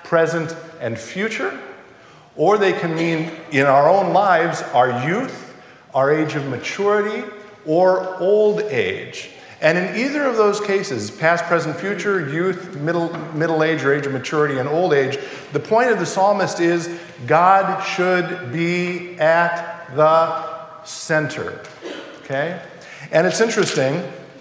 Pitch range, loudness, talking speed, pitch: 160-195 Hz, -19 LUFS, 140 wpm, 170 Hz